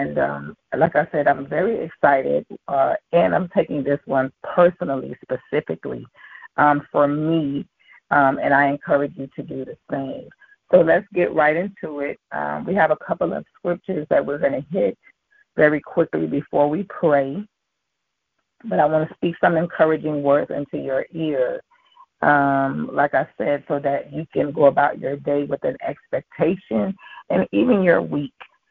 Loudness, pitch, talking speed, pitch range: -21 LUFS, 150 Hz, 170 wpm, 140-175 Hz